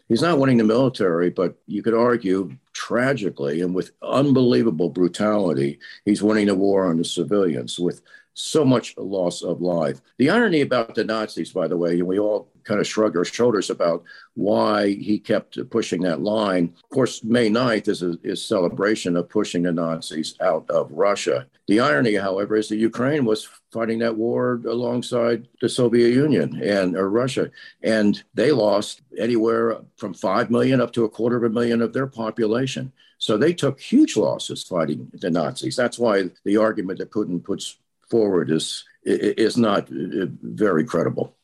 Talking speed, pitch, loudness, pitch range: 175 wpm, 110 Hz, -21 LUFS, 90-120 Hz